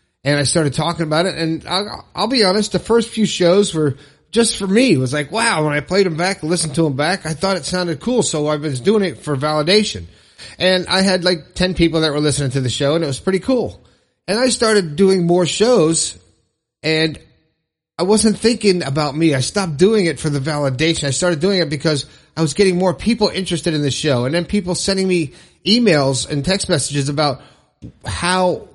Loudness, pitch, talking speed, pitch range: -17 LUFS, 165 Hz, 220 wpm, 150-190 Hz